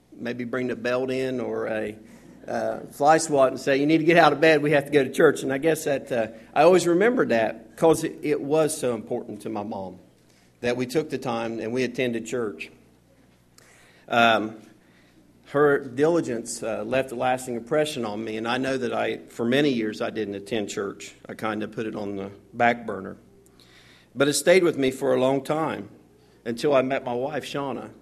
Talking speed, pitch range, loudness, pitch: 210 wpm, 110-140 Hz, -24 LUFS, 125 Hz